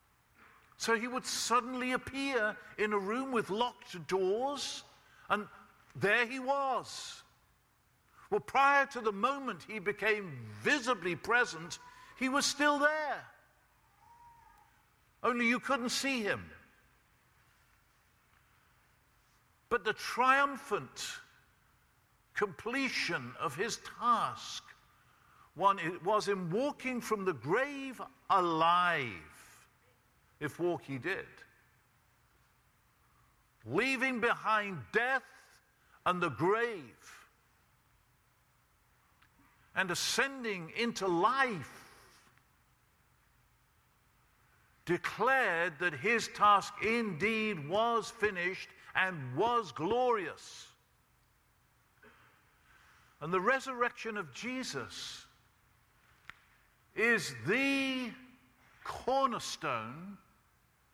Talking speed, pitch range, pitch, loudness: 80 wpm, 195-260 Hz, 230 Hz, -33 LUFS